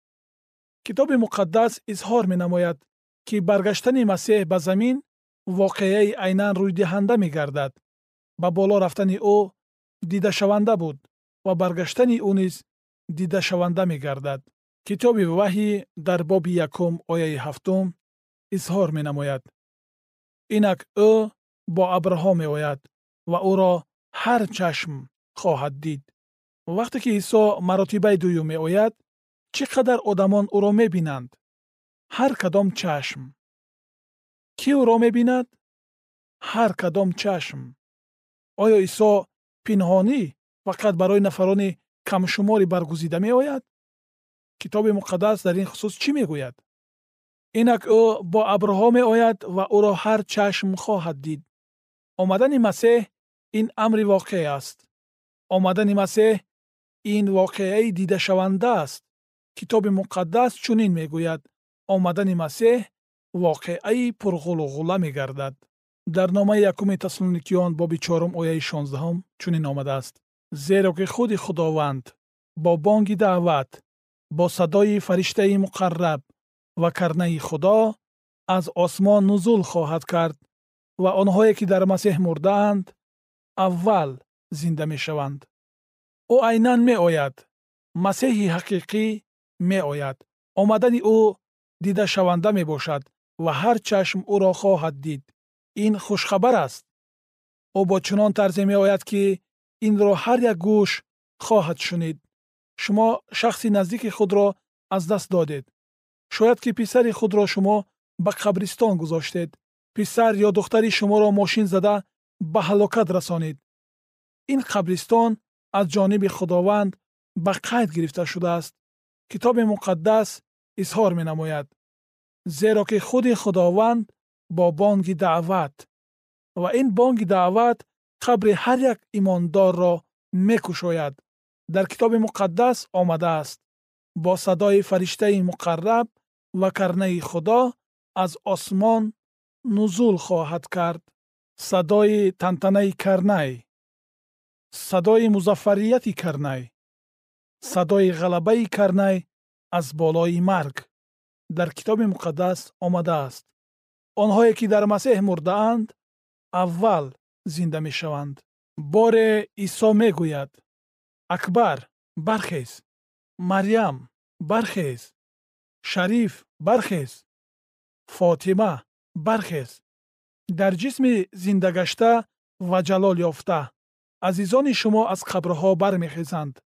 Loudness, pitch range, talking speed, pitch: -21 LUFS, 170-210 Hz, 100 wpm, 190 Hz